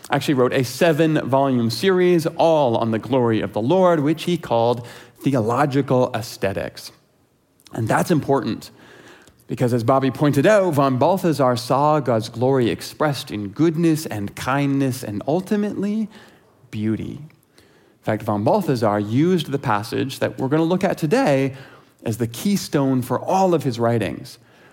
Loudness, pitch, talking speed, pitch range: -20 LUFS, 135 Hz, 150 wpm, 120-160 Hz